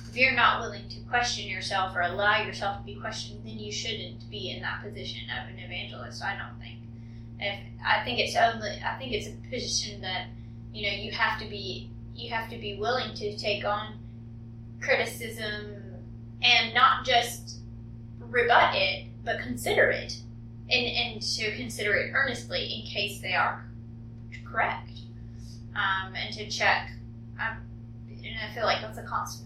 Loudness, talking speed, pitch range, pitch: -28 LUFS, 170 wpm, 115-120 Hz, 115 Hz